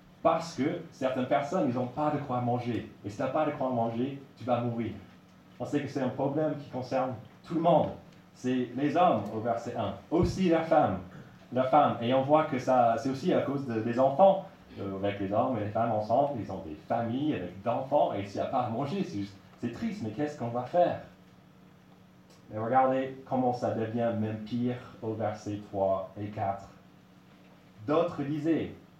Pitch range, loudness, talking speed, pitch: 110-140 Hz, -30 LUFS, 205 wpm, 125 Hz